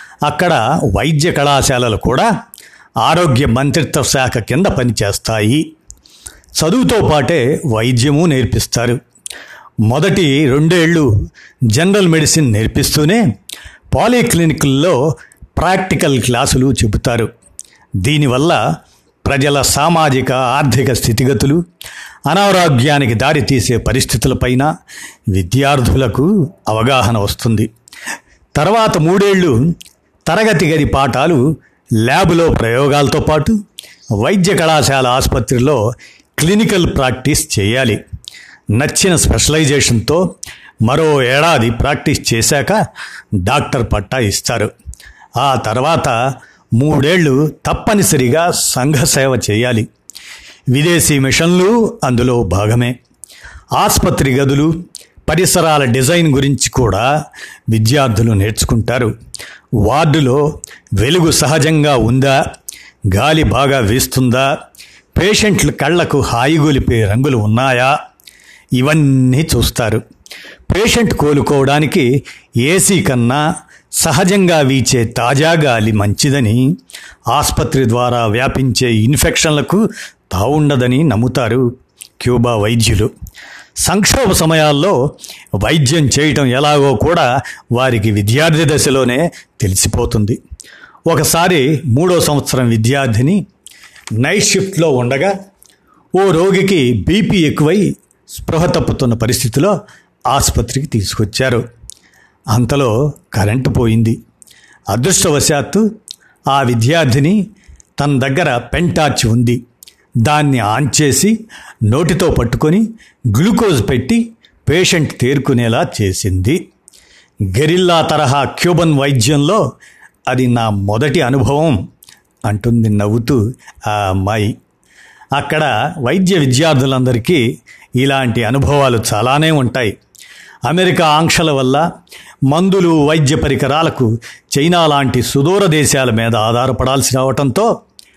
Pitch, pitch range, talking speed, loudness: 135 Hz, 120-155 Hz, 80 wpm, -12 LUFS